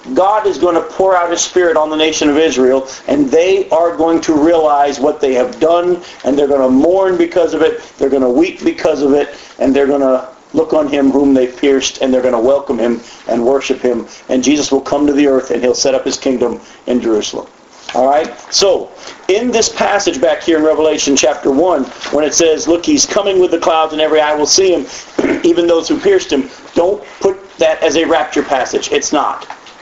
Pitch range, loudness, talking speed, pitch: 140-185 Hz, -12 LUFS, 225 wpm, 155 Hz